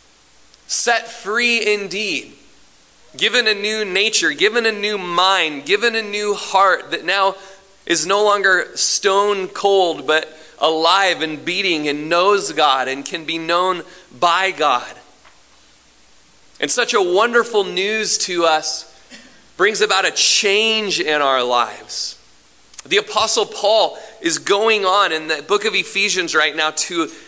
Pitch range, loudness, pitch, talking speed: 160-210 Hz, -16 LUFS, 190 Hz, 140 wpm